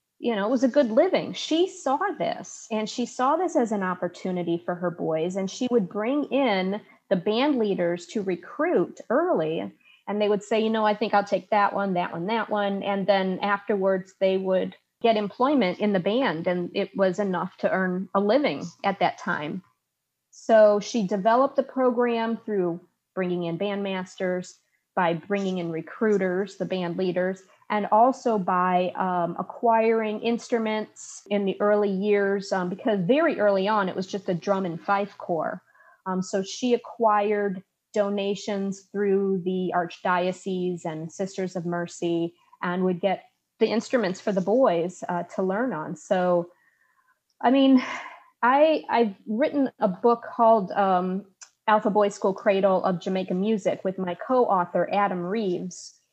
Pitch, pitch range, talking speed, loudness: 200 Hz, 185-225 Hz, 165 wpm, -25 LUFS